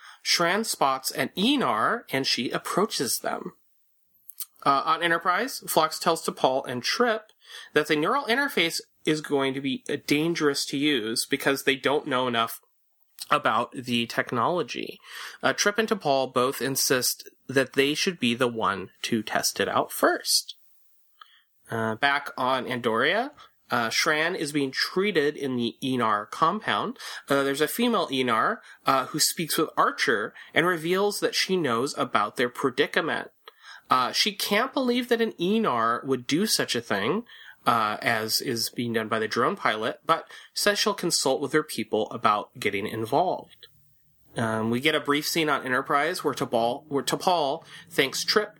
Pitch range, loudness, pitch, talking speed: 130-185 Hz, -25 LUFS, 145 Hz, 160 wpm